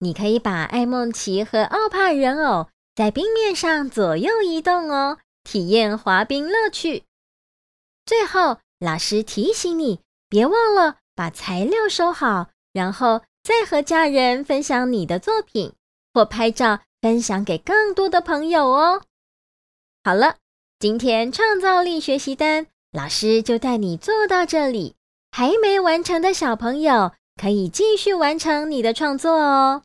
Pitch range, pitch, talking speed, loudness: 220-355 Hz, 275 Hz, 210 characters per minute, -19 LUFS